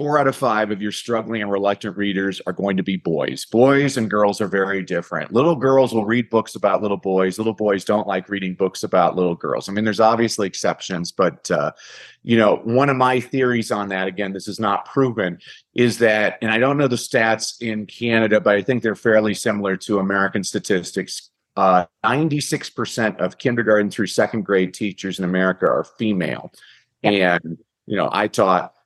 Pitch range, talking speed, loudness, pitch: 95-115 Hz, 195 wpm, -20 LUFS, 105 Hz